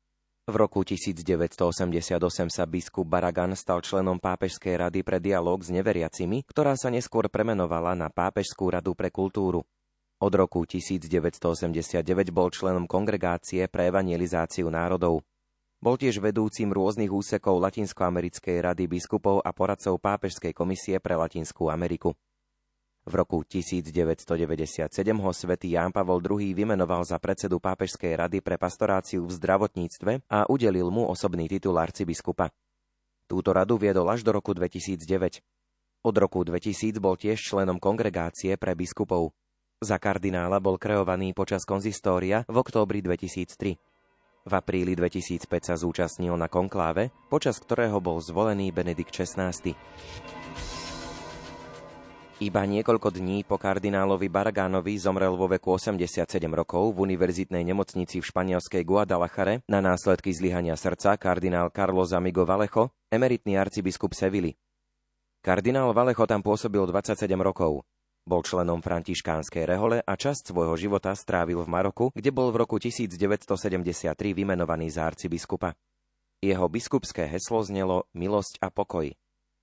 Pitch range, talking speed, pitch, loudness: 90-100 Hz, 125 wpm, 95 Hz, -27 LUFS